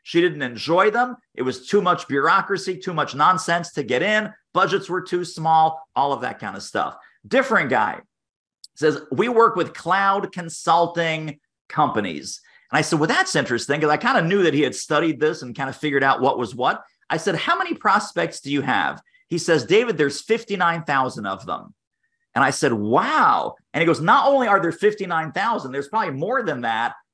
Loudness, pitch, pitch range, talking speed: -21 LUFS, 170 Hz, 150-200 Hz, 200 wpm